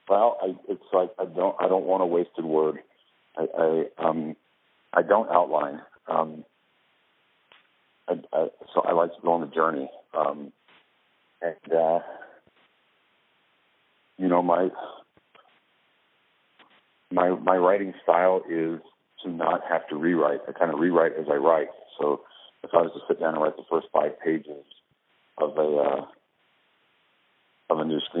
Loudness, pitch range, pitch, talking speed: -25 LUFS, 80-90 Hz, 85 Hz, 155 wpm